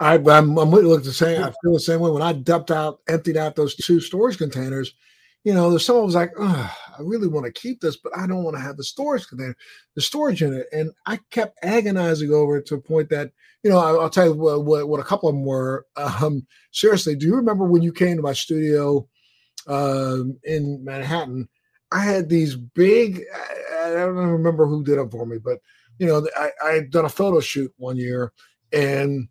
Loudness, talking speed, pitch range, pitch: -20 LUFS, 225 wpm, 140-175 Hz, 155 Hz